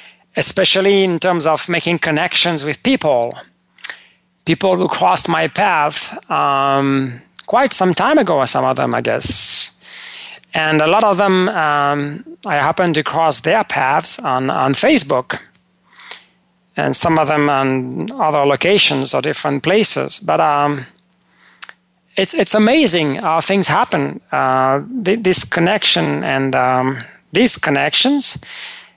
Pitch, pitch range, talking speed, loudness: 165 Hz, 145-190 Hz, 135 wpm, -14 LUFS